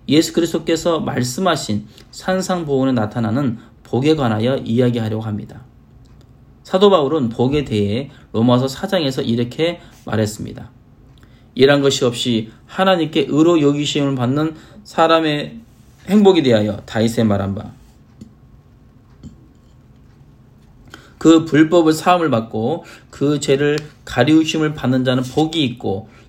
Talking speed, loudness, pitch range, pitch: 265 characters per minute, -17 LUFS, 115-155 Hz, 130 Hz